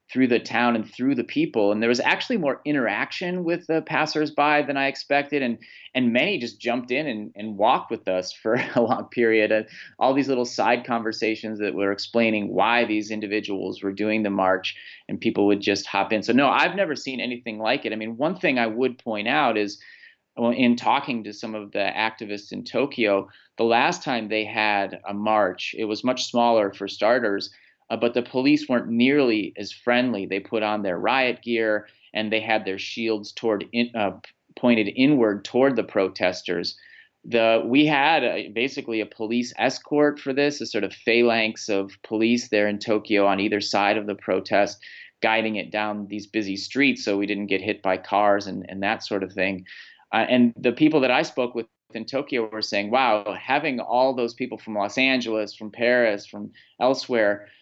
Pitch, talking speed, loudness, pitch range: 110 Hz, 200 wpm, -23 LUFS, 105-125 Hz